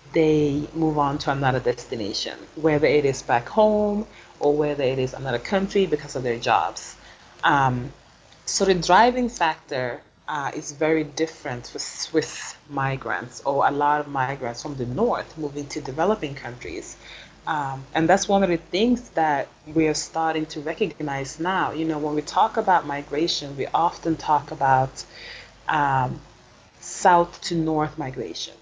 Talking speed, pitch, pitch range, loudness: 155 wpm, 150 Hz, 140-165 Hz, -23 LUFS